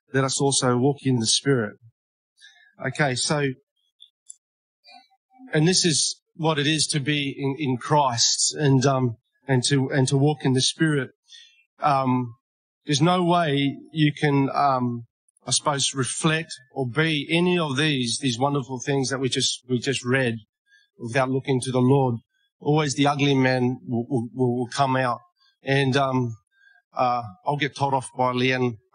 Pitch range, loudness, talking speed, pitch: 130-150 Hz, -23 LUFS, 160 wpm, 135 Hz